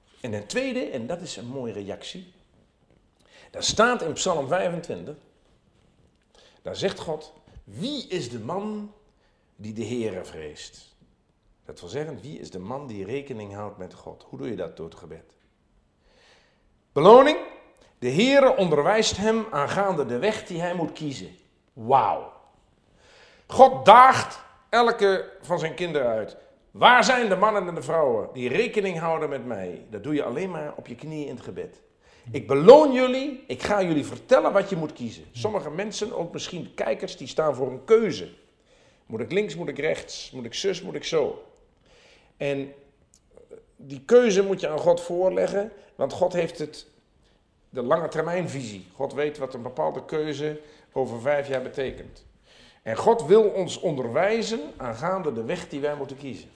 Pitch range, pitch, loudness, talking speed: 140-230 Hz, 175 Hz, -23 LUFS, 165 wpm